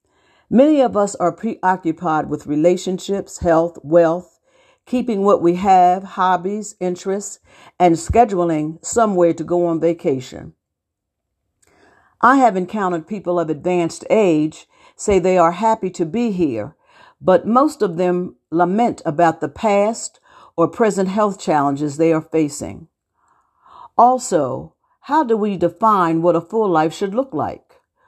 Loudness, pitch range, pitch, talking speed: -17 LUFS, 165-215 Hz, 180 Hz, 135 wpm